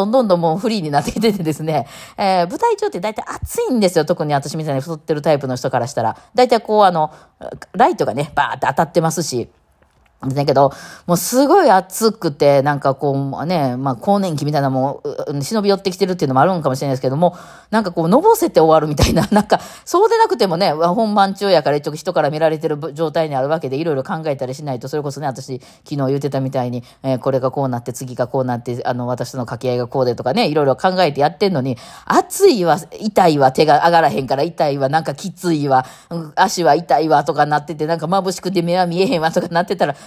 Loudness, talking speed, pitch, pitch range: -17 LUFS, 485 characters per minute, 155 Hz, 135-185 Hz